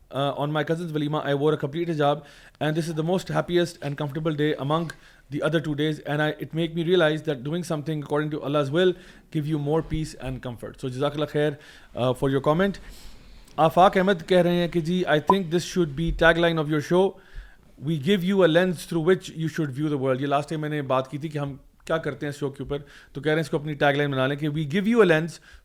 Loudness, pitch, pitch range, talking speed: -24 LUFS, 155 Hz, 145-170 Hz, 230 wpm